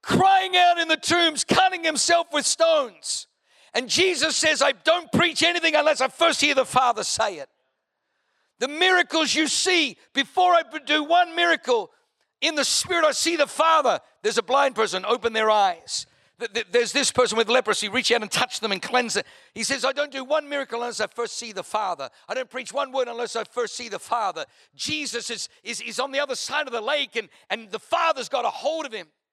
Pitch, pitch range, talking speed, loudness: 280 Hz, 235-320 Hz, 215 wpm, -22 LUFS